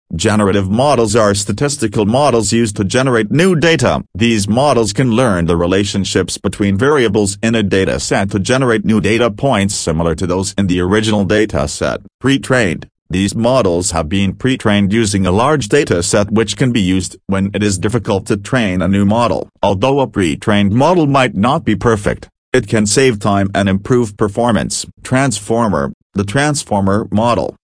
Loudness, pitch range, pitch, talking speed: -14 LUFS, 100-120 Hz, 105 Hz, 170 wpm